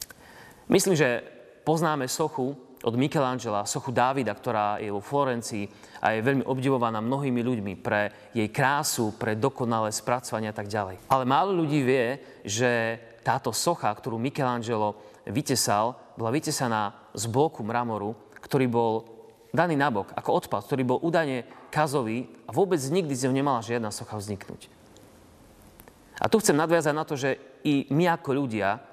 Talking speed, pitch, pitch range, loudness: 150 wpm, 125 Hz, 110-140 Hz, -27 LUFS